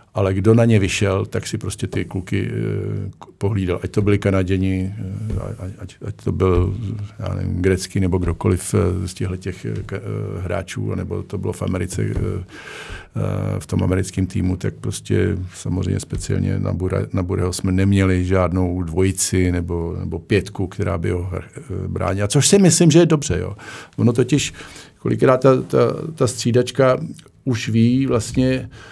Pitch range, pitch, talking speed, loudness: 95-115 Hz, 100 Hz, 150 wpm, -20 LUFS